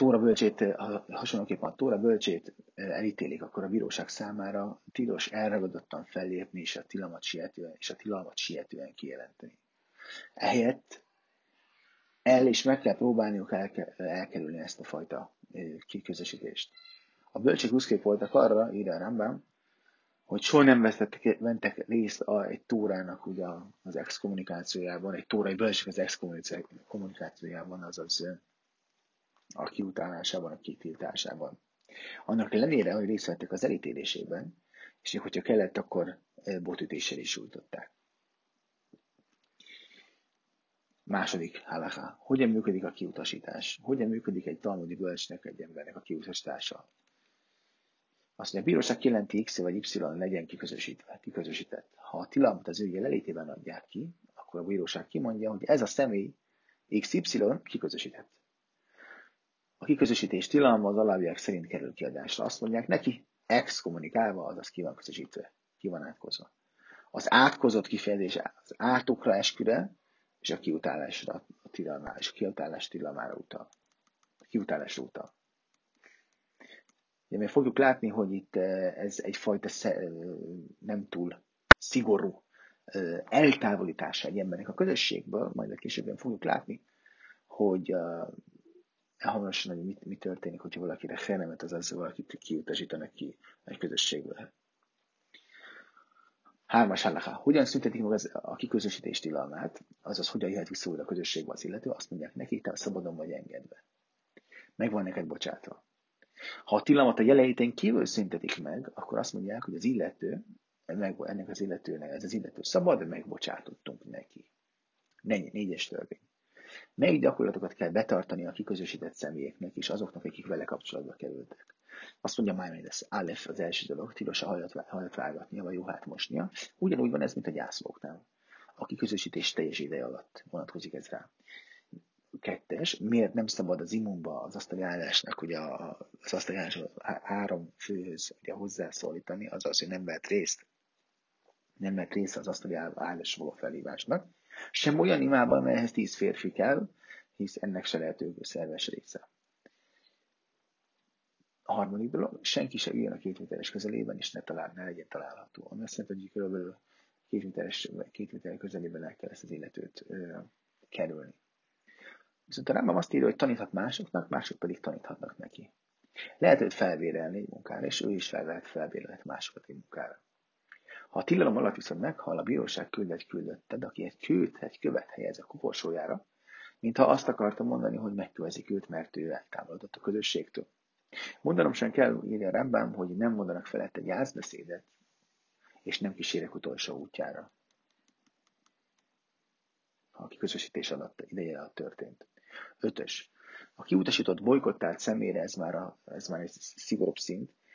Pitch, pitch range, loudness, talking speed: 105 Hz, 95-130 Hz, -32 LUFS, 135 wpm